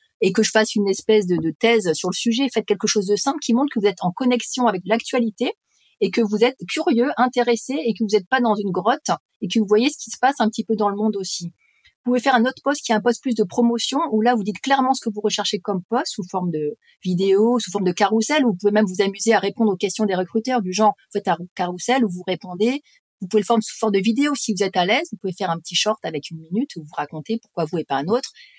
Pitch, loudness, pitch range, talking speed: 220 Hz, -20 LUFS, 195-245 Hz, 290 wpm